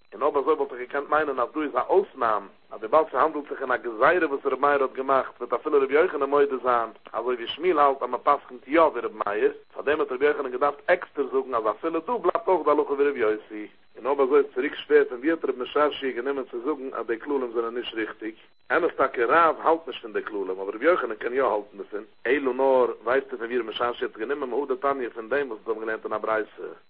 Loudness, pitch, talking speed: -25 LUFS, 150 Hz, 240 wpm